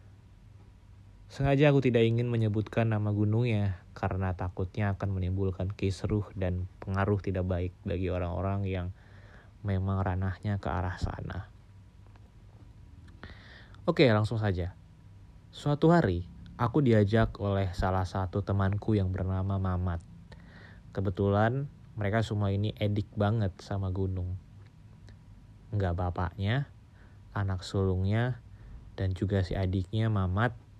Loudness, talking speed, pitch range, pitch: -30 LUFS, 105 wpm, 95-105 Hz, 100 Hz